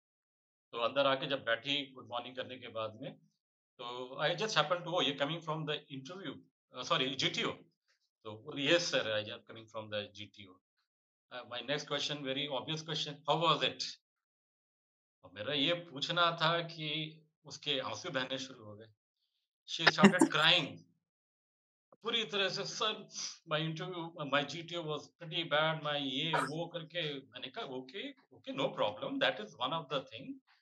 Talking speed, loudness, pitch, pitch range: 165 wpm, -34 LUFS, 145 Hz, 125-165 Hz